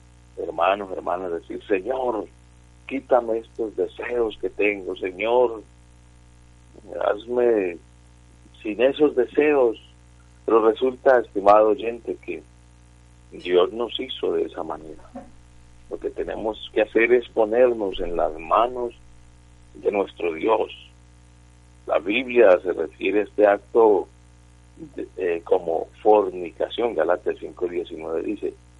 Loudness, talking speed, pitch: -22 LUFS, 110 wpm, 100 Hz